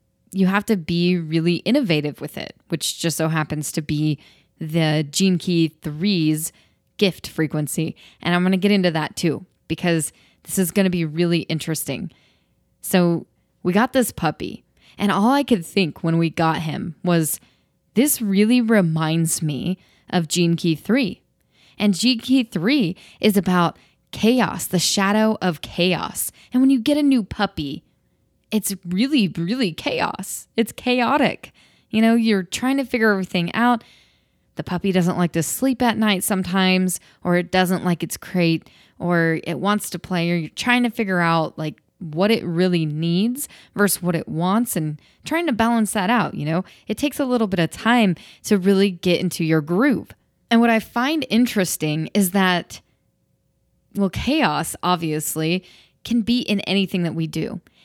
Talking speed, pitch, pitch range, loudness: 170 wpm, 180 Hz, 165-215 Hz, -20 LUFS